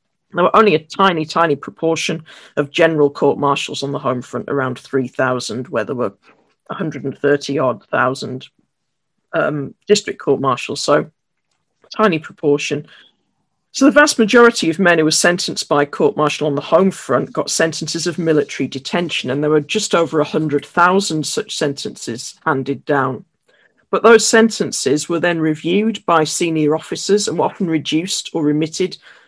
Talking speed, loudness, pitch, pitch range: 150 wpm, -16 LUFS, 160 Hz, 145-180 Hz